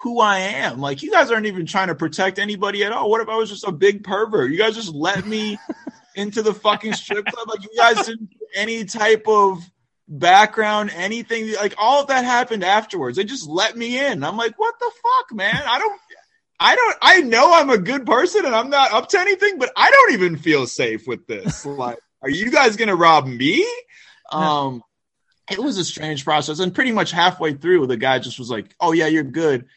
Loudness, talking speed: -18 LUFS, 225 wpm